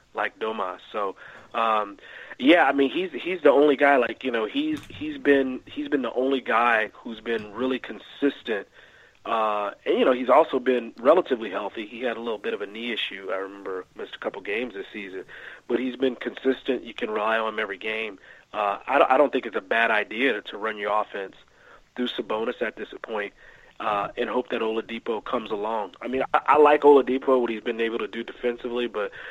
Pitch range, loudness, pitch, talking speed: 110-135 Hz, -24 LUFS, 125 Hz, 215 wpm